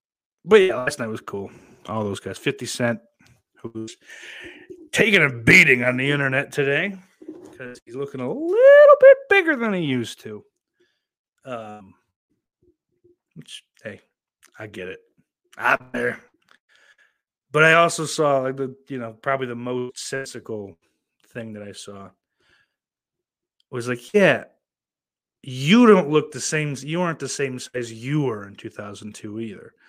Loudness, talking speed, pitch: -18 LUFS, 145 wpm, 135 Hz